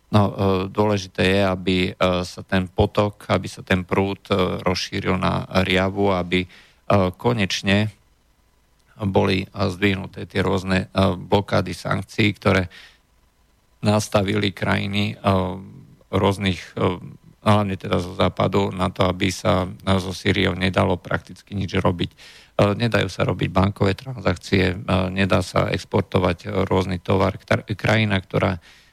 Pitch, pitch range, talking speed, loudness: 95 Hz, 95-105 Hz, 110 wpm, -21 LUFS